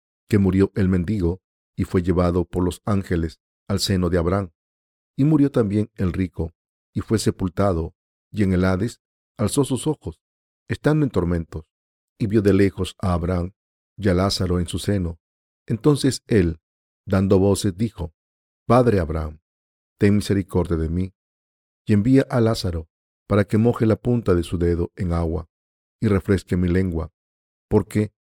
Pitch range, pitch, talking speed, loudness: 80-105 Hz, 95 Hz, 155 wpm, -22 LUFS